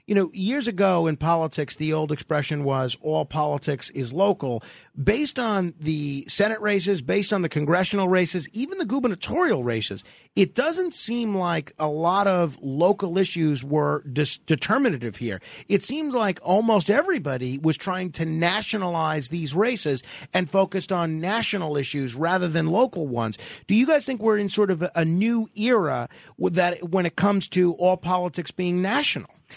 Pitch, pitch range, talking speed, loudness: 180 Hz, 150-200 Hz, 170 wpm, -24 LUFS